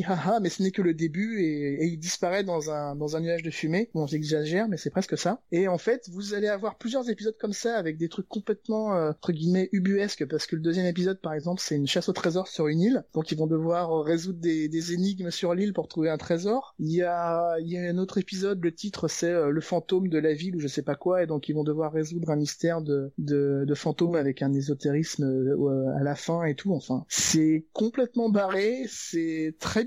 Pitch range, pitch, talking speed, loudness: 155-190 Hz, 170 Hz, 240 wpm, -27 LUFS